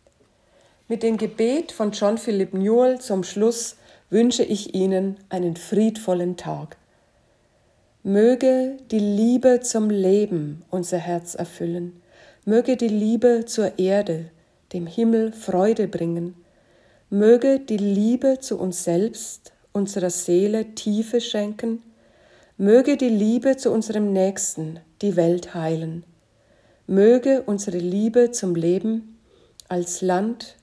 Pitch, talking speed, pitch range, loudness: 205 Hz, 115 wpm, 180-230 Hz, -21 LUFS